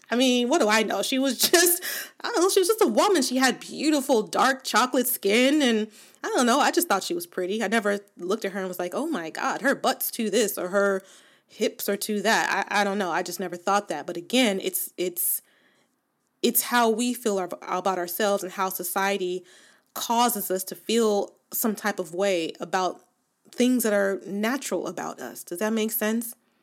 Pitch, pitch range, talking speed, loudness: 210 Hz, 190-255 Hz, 215 wpm, -24 LUFS